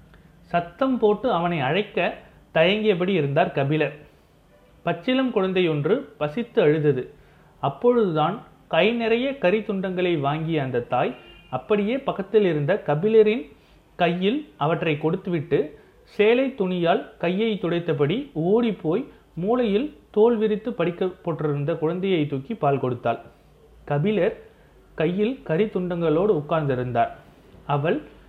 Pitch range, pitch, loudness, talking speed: 155-215 Hz, 175 Hz, -23 LUFS, 95 wpm